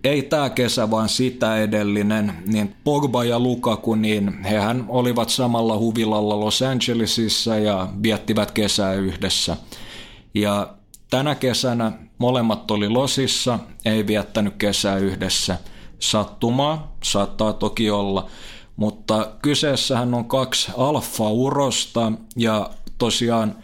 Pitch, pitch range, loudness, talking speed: 110 Hz, 105-125 Hz, -21 LUFS, 105 wpm